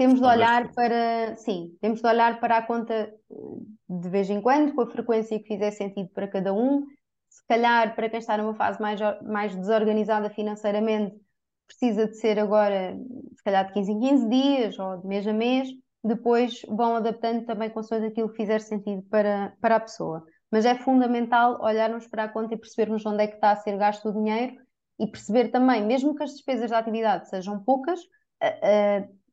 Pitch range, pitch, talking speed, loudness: 210-240 Hz, 220 Hz, 180 wpm, -25 LUFS